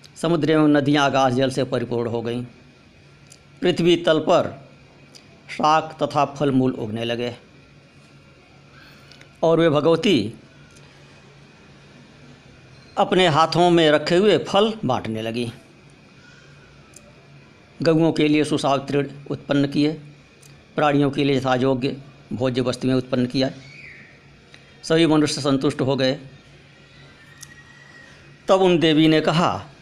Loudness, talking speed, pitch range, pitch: -20 LUFS, 105 wpm, 130-155 Hz, 140 Hz